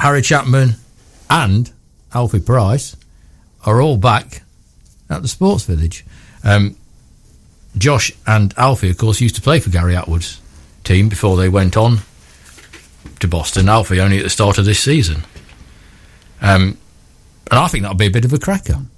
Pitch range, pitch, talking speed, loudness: 90-120 Hz, 100 Hz, 160 wpm, -14 LUFS